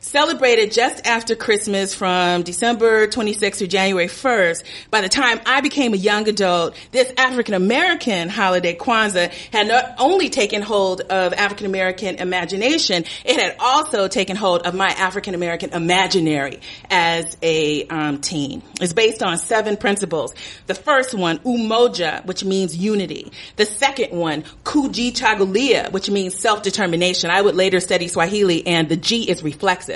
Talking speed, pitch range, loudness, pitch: 145 wpm, 180-230 Hz, -18 LUFS, 195 Hz